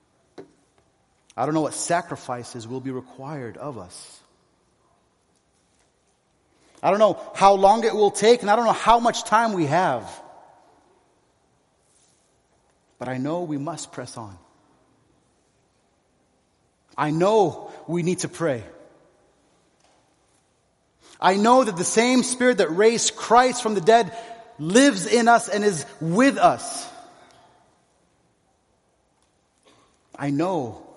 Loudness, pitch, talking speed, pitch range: -21 LUFS, 190 Hz, 120 wpm, 150-230 Hz